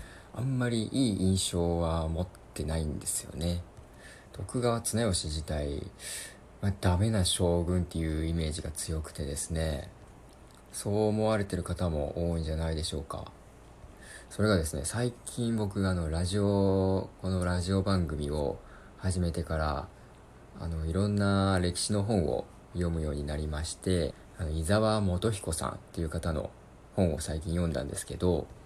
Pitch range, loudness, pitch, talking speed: 80-100 Hz, -31 LUFS, 90 Hz, 300 characters per minute